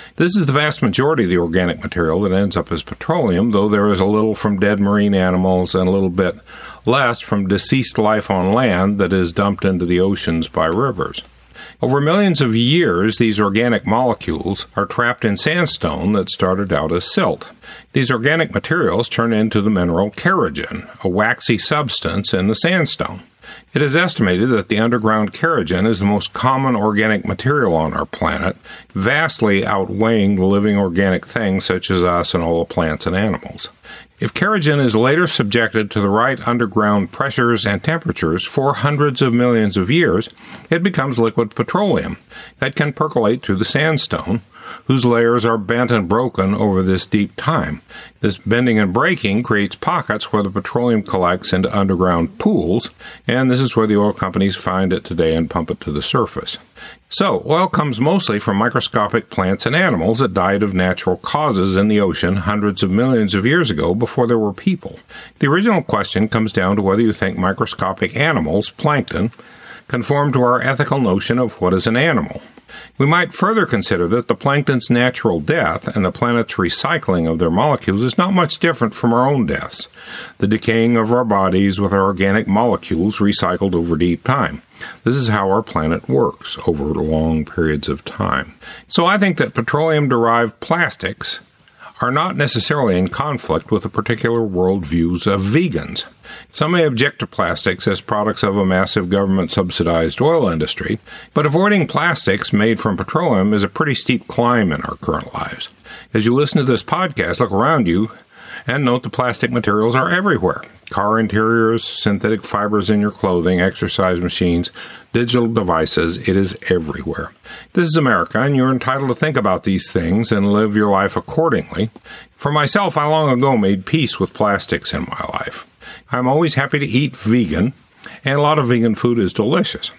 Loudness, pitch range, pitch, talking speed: -17 LUFS, 95-125 Hz, 110 Hz, 180 wpm